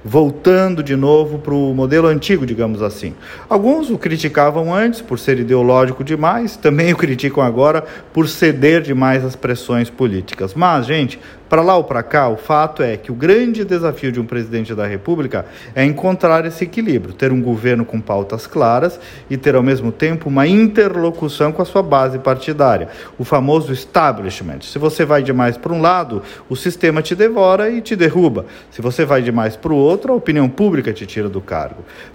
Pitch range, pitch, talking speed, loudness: 125-170 Hz, 145 Hz, 185 wpm, -15 LUFS